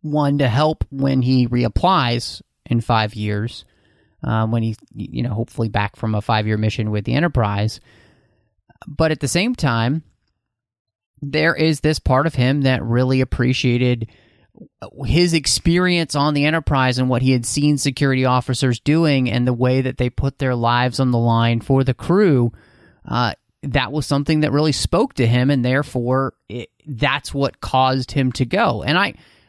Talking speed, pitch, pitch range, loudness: 175 wpm, 130 Hz, 115-145 Hz, -18 LUFS